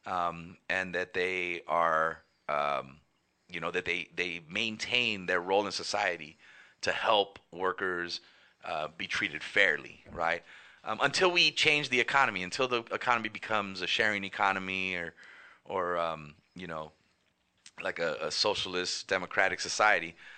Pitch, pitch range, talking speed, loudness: 95 Hz, 85-110 Hz, 140 wpm, -30 LUFS